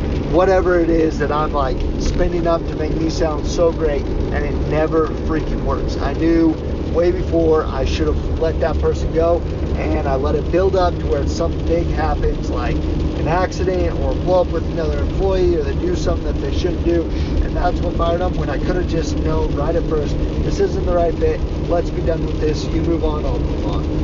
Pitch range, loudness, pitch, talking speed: 75-80 Hz, -19 LUFS, 75 Hz, 220 wpm